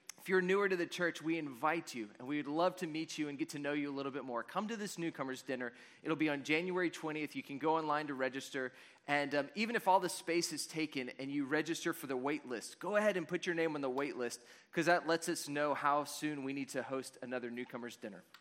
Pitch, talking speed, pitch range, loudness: 150 Hz, 265 wpm, 135-170 Hz, -37 LUFS